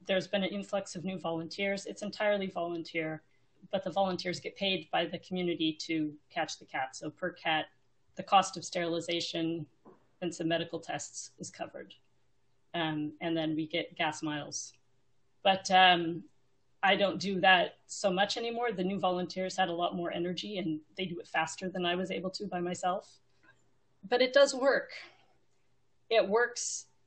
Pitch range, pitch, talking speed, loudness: 155-190 Hz, 170 Hz, 170 wpm, -32 LUFS